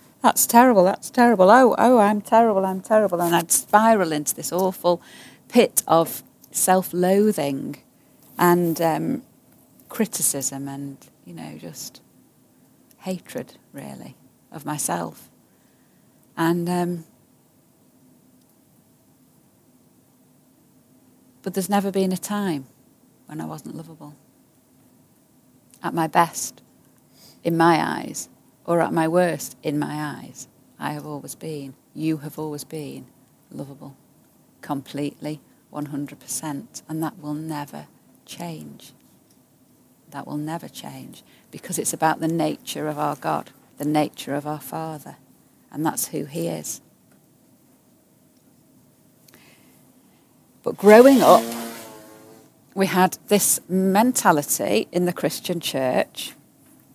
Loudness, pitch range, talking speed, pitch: -21 LUFS, 145-185 Hz, 110 wpm, 160 Hz